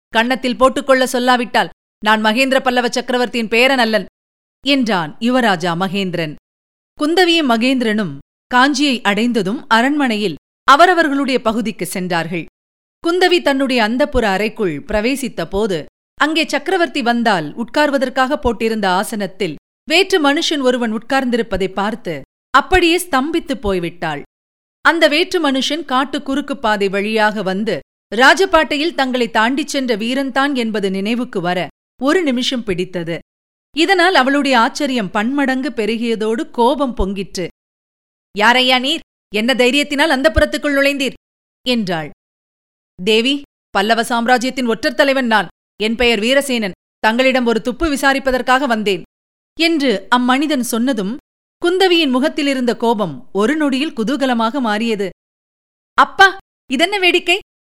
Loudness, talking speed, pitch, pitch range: -15 LUFS, 105 wpm, 245 Hz, 215-280 Hz